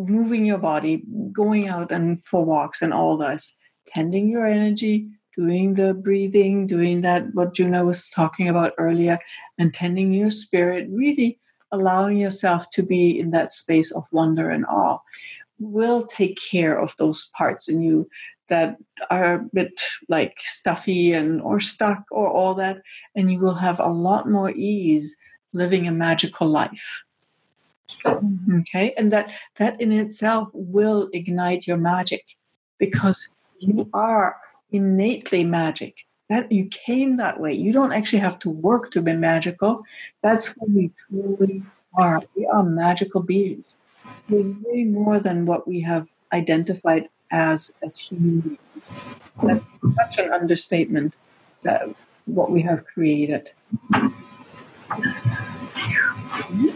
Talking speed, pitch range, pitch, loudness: 140 wpm, 170-210 Hz, 190 Hz, -21 LUFS